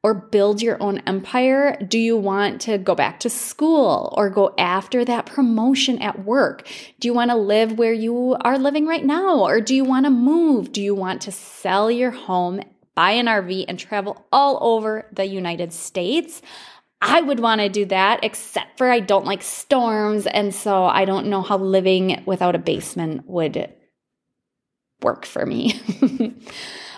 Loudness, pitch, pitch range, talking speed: -19 LUFS, 215 Hz, 195-250 Hz, 180 wpm